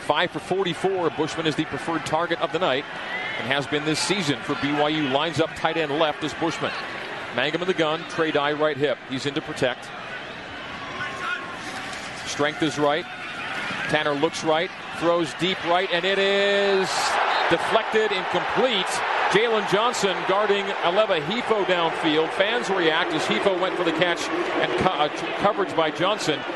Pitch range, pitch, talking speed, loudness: 150-180 Hz, 160 Hz, 160 wpm, -23 LUFS